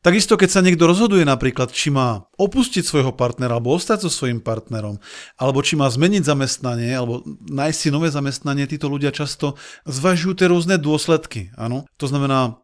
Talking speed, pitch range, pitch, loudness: 170 wpm, 125-170 Hz, 140 Hz, -19 LUFS